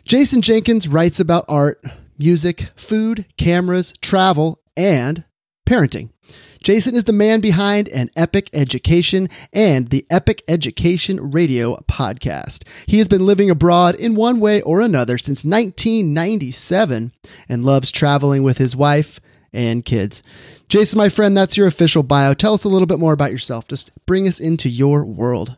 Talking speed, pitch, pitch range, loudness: 155 wpm, 170 Hz, 135-200 Hz, -15 LUFS